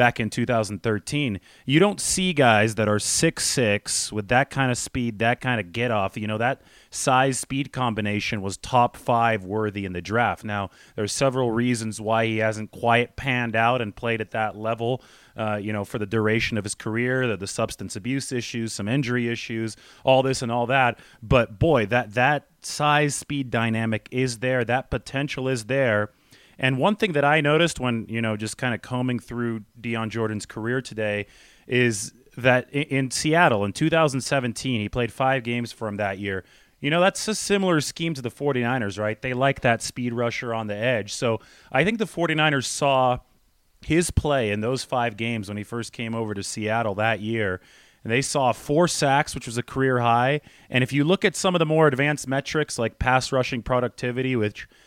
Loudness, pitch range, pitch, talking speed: -24 LUFS, 110-135 Hz, 120 Hz, 190 wpm